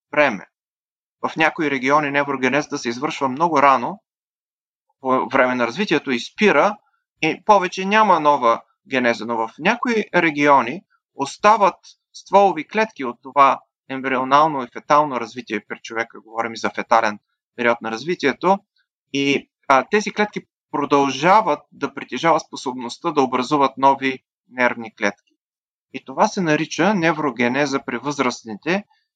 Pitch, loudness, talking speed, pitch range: 140 Hz, -19 LUFS, 130 wpm, 125-170 Hz